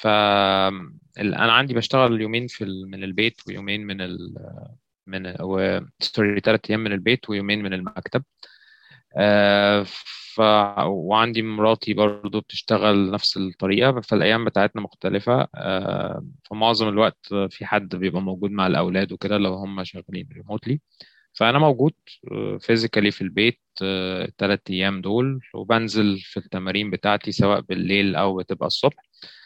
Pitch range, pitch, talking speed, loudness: 95-110 Hz, 105 Hz, 120 wpm, -22 LUFS